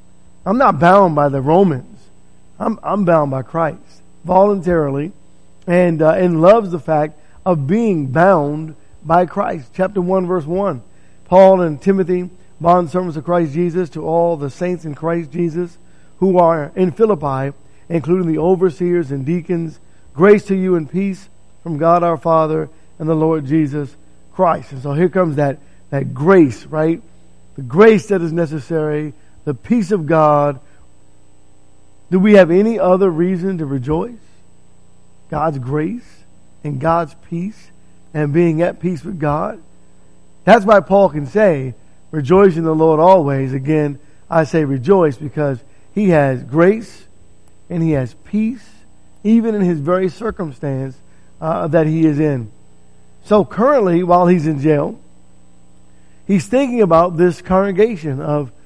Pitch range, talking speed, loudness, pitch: 145-185 Hz, 150 wpm, -15 LUFS, 165 Hz